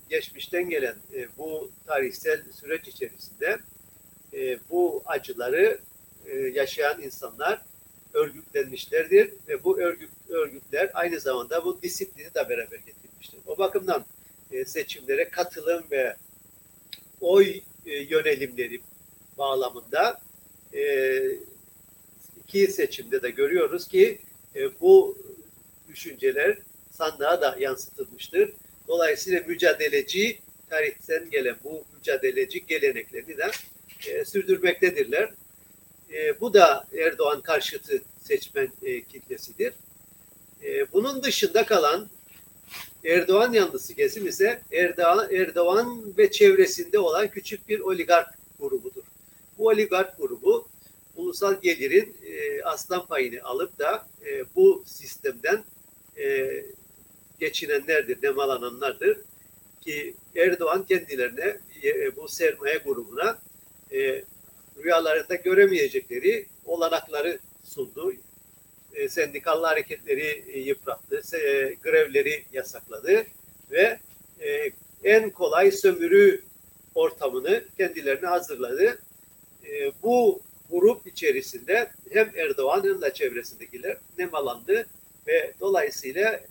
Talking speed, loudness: 85 wpm, -25 LUFS